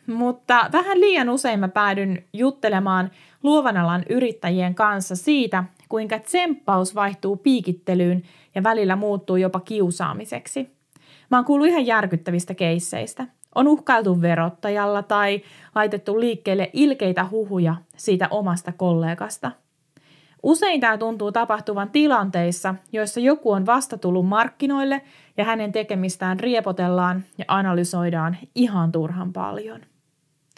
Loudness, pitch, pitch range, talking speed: -21 LUFS, 200 Hz, 180-230 Hz, 110 wpm